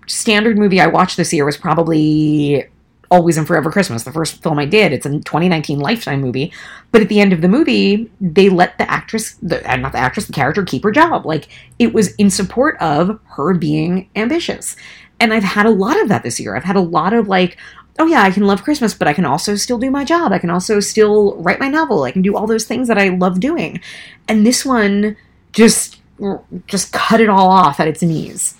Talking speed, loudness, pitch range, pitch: 230 wpm, -14 LUFS, 170-220 Hz, 195 Hz